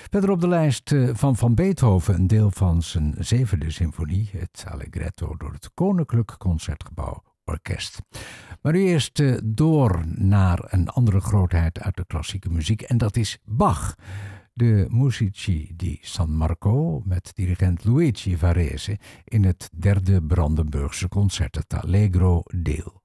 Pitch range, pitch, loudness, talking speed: 85-115 Hz, 95 Hz, -22 LUFS, 140 wpm